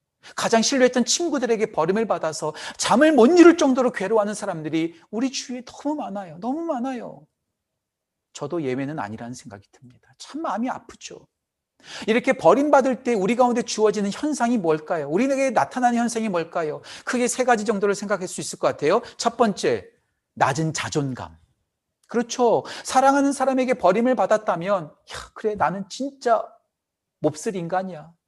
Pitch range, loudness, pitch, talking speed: 175-255 Hz, -22 LUFS, 225 Hz, 350 characters per minute